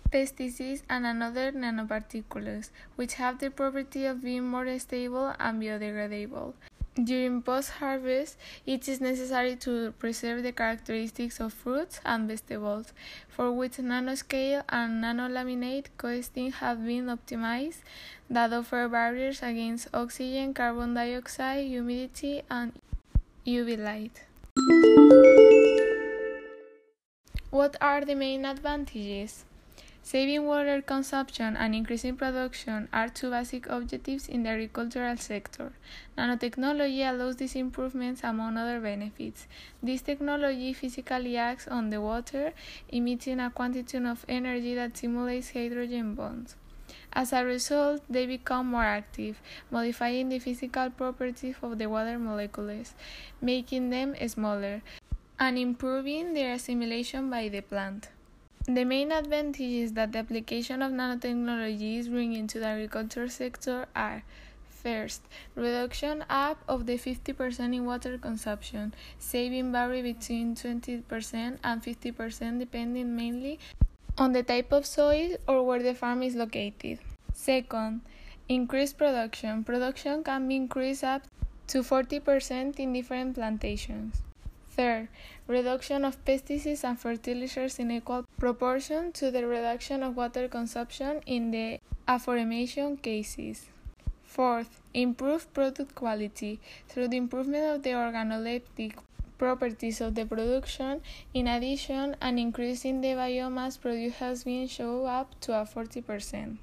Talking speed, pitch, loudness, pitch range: 120 wpm, 250 Hz, -29 LUFS, 235-265 Hz